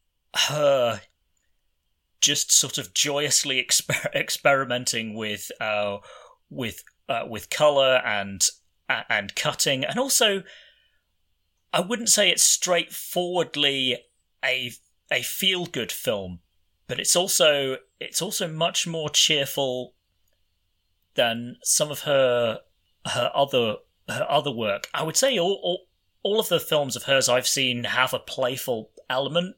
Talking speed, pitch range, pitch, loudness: 125 wpm, 105-170 Hz, 135 Hz, -23 LUFS